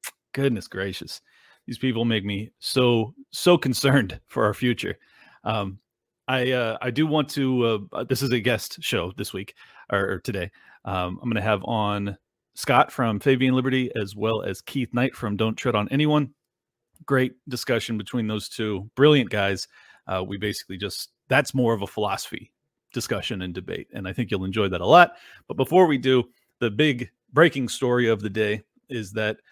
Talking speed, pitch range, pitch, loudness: 185 wpm, 105-130 Hz, 115 Hz, -24 LUFS